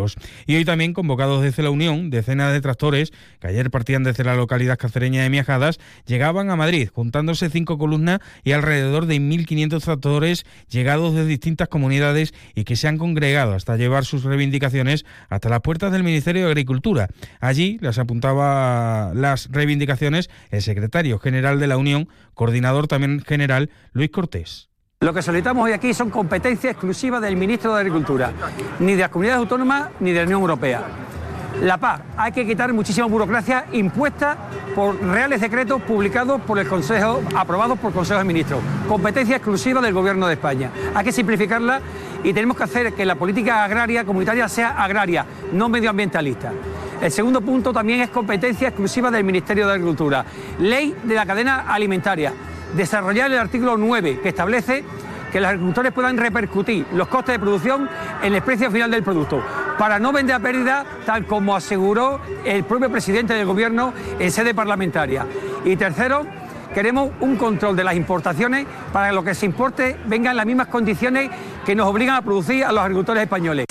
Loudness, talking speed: -19 LUFS, 175 wpm